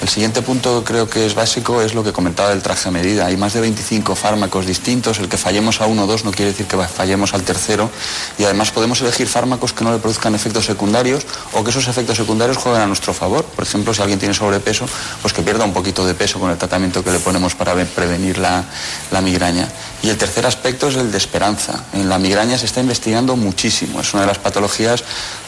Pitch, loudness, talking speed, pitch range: 105 Hz, -16 LUFS, 235 wpm, 95-115 Hz